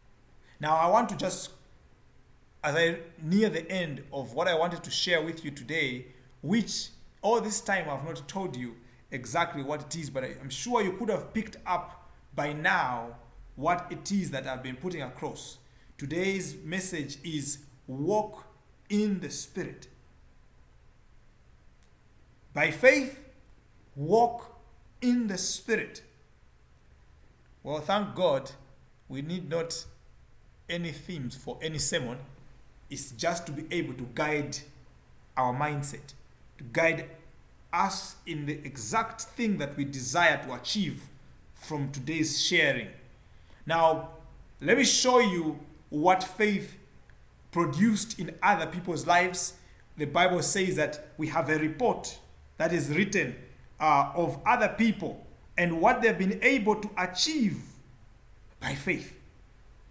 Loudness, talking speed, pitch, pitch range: -29 LUFS, 135 wpm, 160 Hz, 130-185 Hz